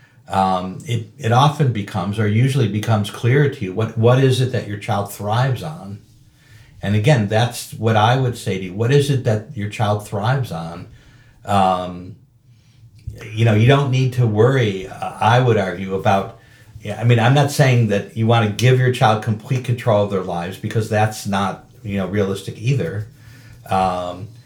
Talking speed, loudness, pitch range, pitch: 185 wpm, -18 LUFS, 105-125 Hz, 115 Hz